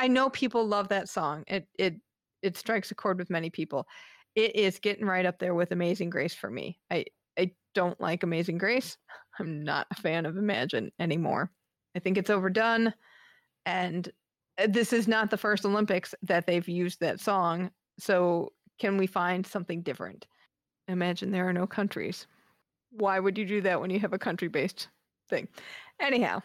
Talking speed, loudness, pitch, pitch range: 180 wpm, -30 LUFS, 190 Hz, 175-210 Hz